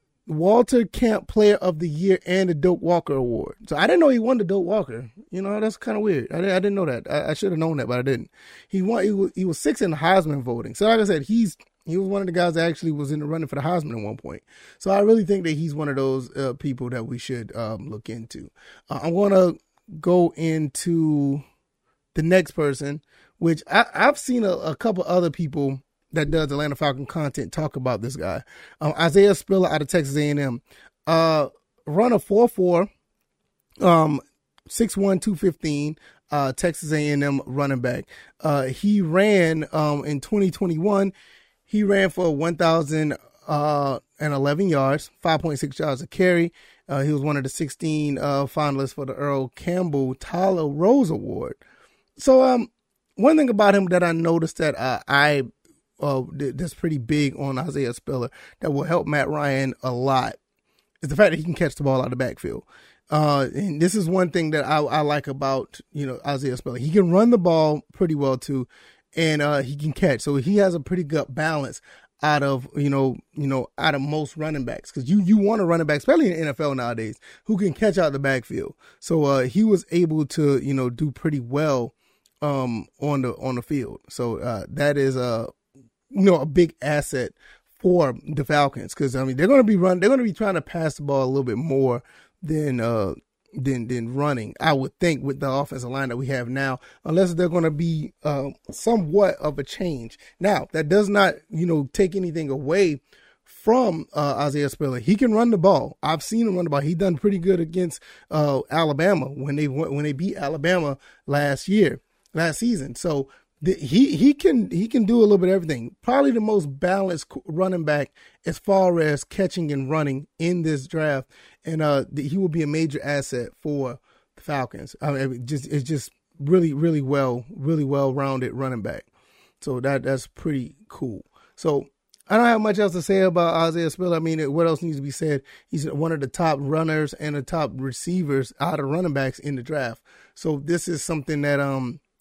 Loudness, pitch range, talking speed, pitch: -22 LUFS, 140-180 Hz, 210 wpm, 155 Hz